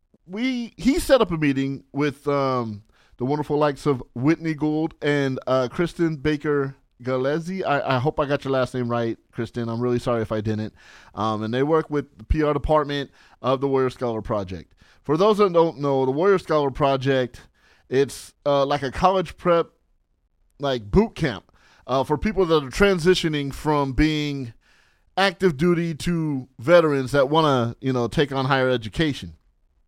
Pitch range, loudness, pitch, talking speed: 125-160 Hz, -22 LUFS, 140 Hz, 175 wpm